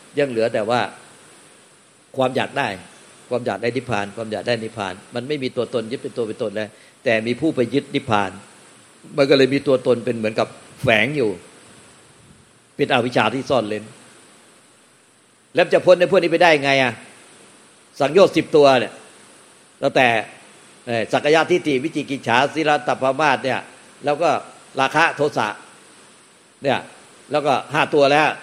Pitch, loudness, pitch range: 130 Hz, -19 LUFS, 110-145 Hz